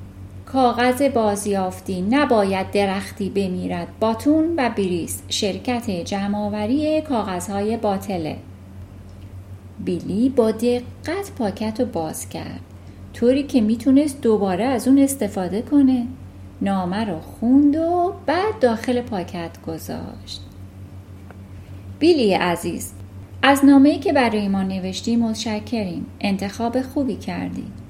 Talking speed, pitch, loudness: 105 wpm, 205 Hz, -20 LUFS